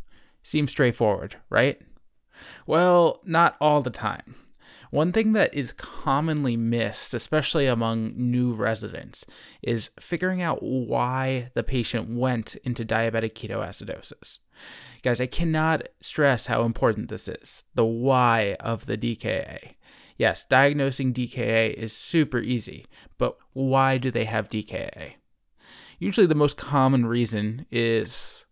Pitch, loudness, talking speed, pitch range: 125 Hz, -24 LUFS, 125 wpm, 115-140 Hz